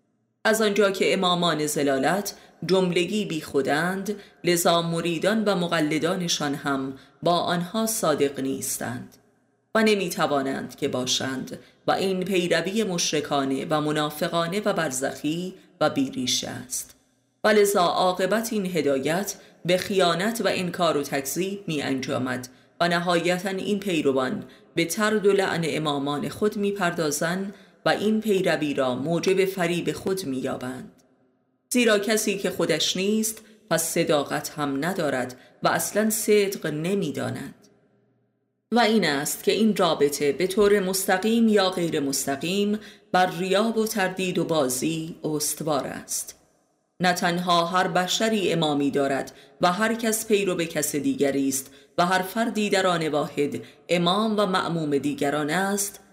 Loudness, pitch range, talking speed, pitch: -24 LUFS, 150-200 Hz, 135 wpm, 175 Hz